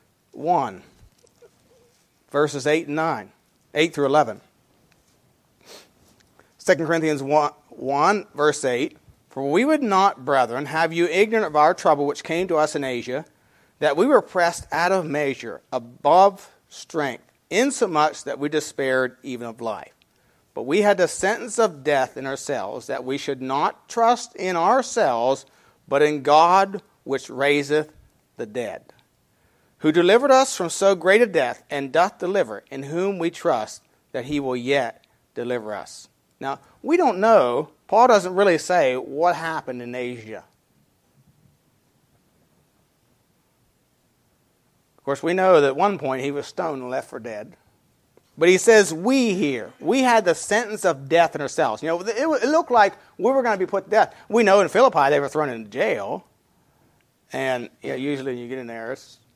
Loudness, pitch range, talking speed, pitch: -21 LUFS, 135-195 Hz, 165 wpm, 155 Hz